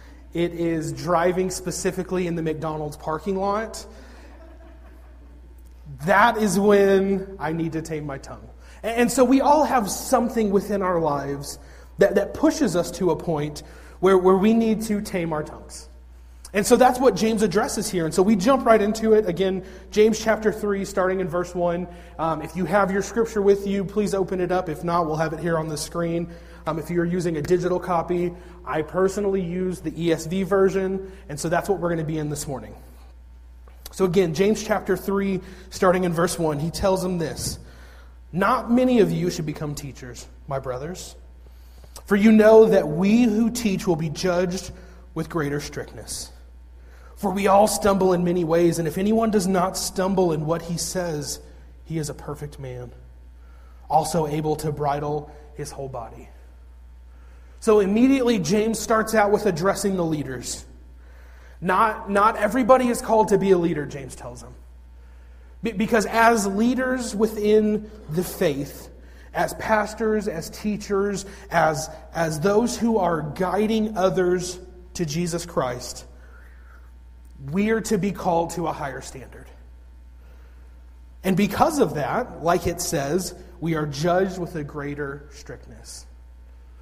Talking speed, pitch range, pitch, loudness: 160 wpm, 140-200 Hz, 175 Hz, -22 LUFS